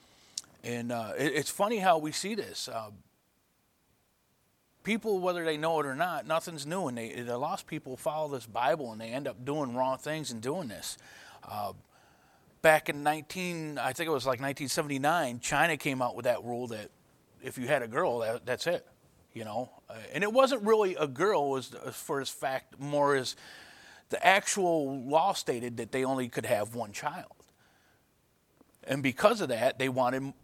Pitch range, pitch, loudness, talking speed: 130-160 Hz, 145 Hz, -31 LUFS, 190 wpm